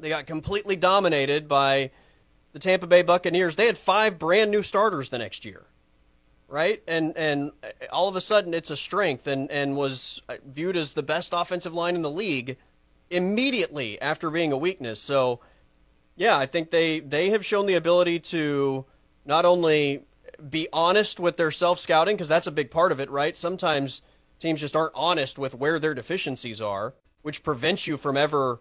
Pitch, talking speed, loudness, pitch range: 155 Hz, 180 wpm, -24 LUFS, 135-175 Hz